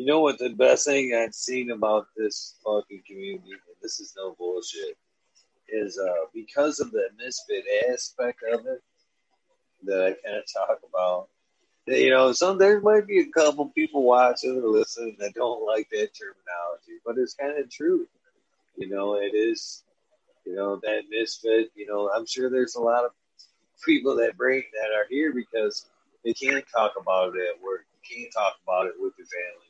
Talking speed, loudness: 190 wpm, -25 LUFS